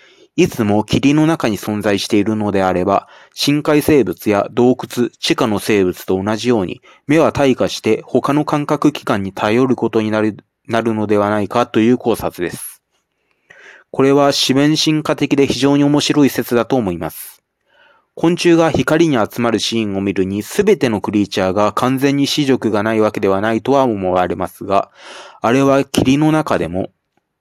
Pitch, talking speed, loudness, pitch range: 120 Hz, 325 characters per minute, -15 LUFS, 105-140 Hz